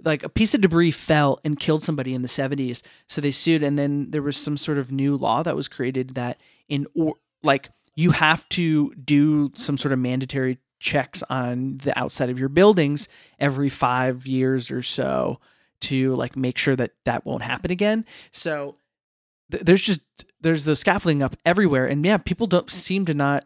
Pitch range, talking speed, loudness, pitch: 130-160 Hz, 195 wpm, -22 LUFS, 145 Hz